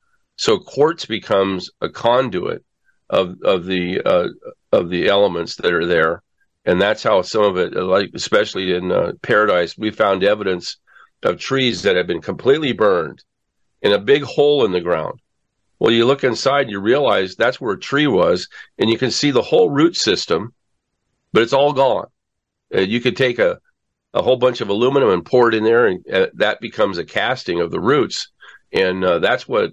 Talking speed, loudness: 190 wpm, -17 LUFS